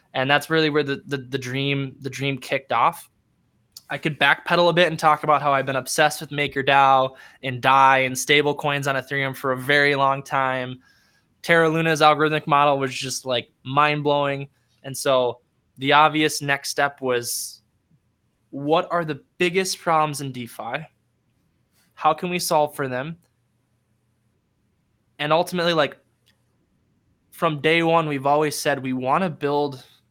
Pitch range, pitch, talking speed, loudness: 130-155 Hz, 140 Hz, 155 wpm, -21 LUFS